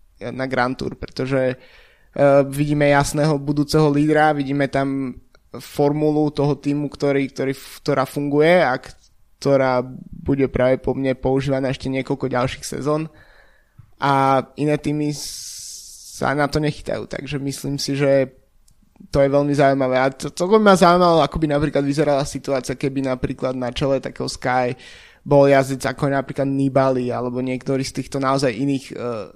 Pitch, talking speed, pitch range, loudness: 140 Hz, 150 wpm, 130-145 Hz, -19 LUFS